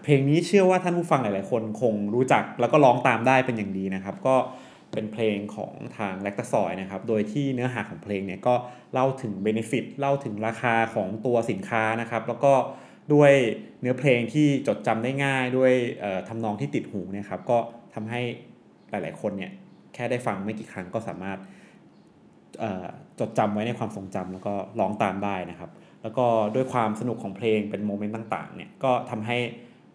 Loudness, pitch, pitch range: -25 LUFS, 115 Hz, 105-130 Hz